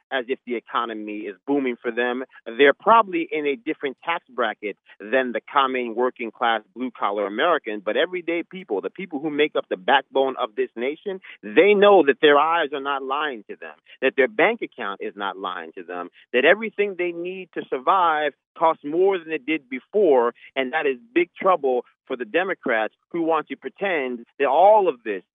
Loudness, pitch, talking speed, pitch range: -22 LUFS, 150 Hz, 195 wpm, 125-185 Hz